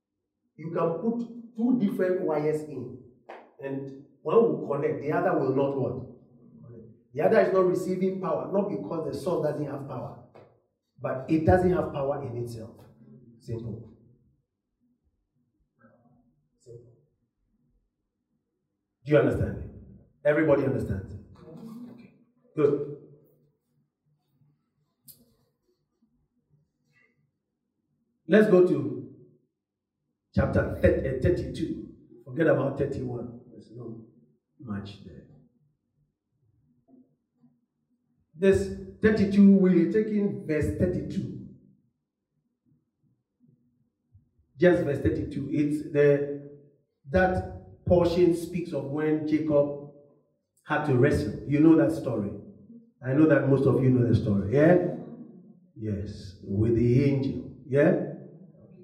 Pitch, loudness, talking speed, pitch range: 145 Hz, -25 LUFS, 100 wpm, 120-180 Hz